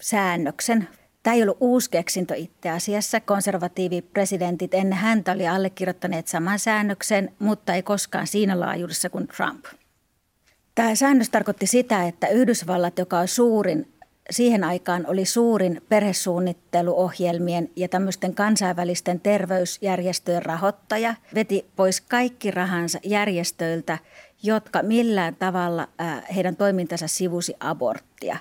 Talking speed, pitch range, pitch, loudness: 110 wpm, 175-210 Hz, 185 Hz, -23 LUFS